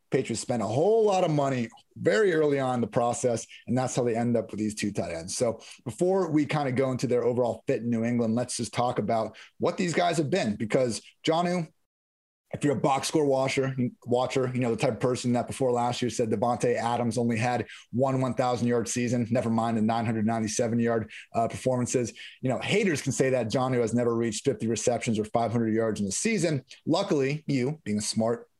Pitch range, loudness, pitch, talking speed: 115-135 Hz, -27 LUFS, 120 Hz, 220 wpm